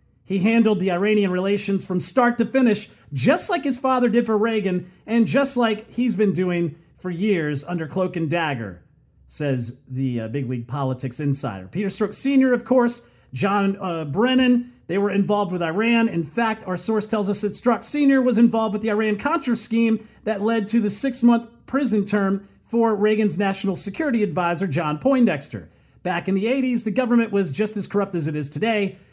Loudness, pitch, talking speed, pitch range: -21 LUFS, 205 Hz, 185 wpm, 175-230 Hz